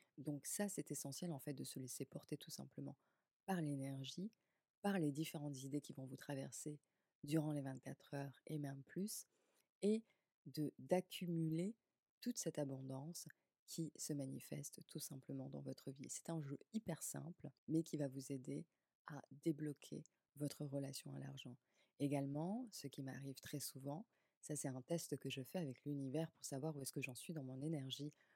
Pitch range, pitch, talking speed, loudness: 135-165 Hz, 145 Hz, 180 wpm, -48 LUFS